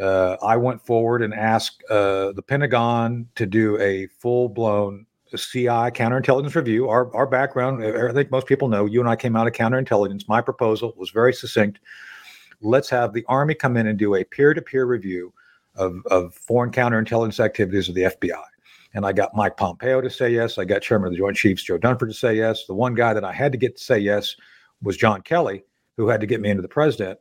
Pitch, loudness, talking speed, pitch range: 115 Hz, -21 LUFS, 220 wpm, 105-125 Hz